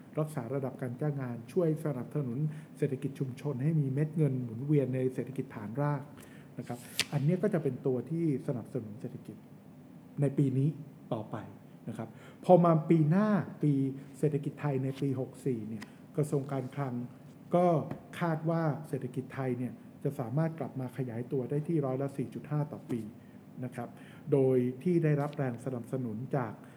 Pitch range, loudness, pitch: 130-150 Hz, -33 LUFS, 140 Hz